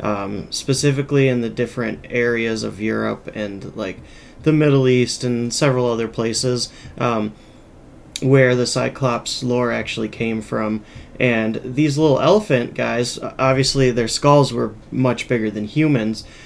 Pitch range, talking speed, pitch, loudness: 110-130 Hz, 140 wpm, 120 Hz, -19 LUFS